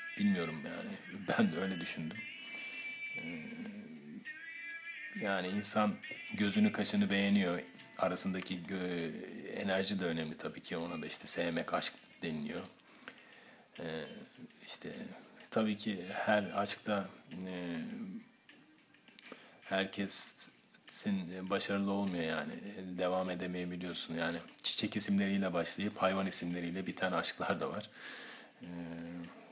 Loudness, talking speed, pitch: -37 LUFS, 90 wpm, 105 Hz